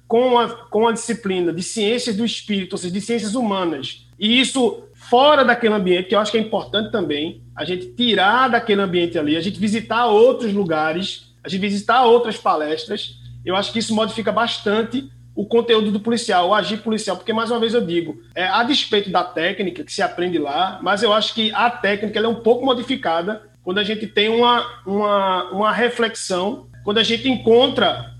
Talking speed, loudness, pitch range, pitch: 200 wpm, -18 LUFS, 180-230 Hz, 215 Hz